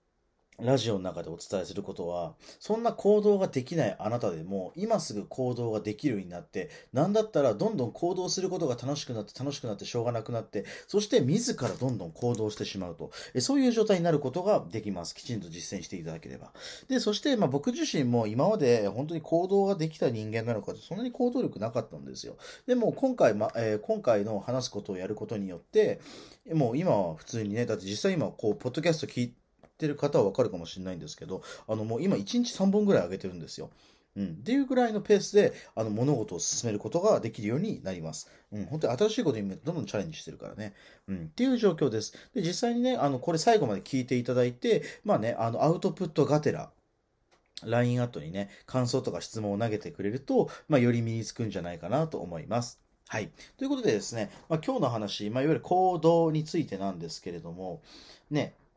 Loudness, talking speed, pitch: -30 LUFS, 415 characters per minute, 130 Hz